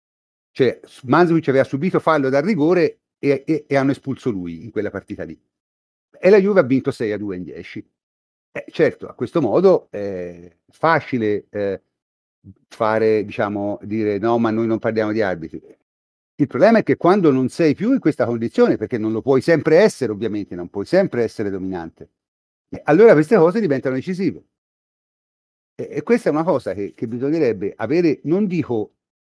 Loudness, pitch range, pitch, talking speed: -18 LUFS, 100-155 Hz, 115 Hz, 175 wpm